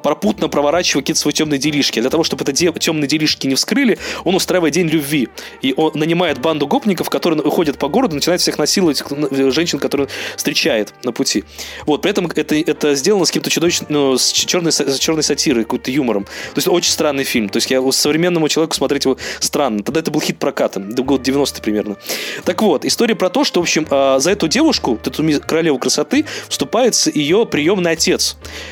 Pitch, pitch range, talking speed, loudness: 155 Hz, 140-175 Hz, 200 wpm, -15 LUFS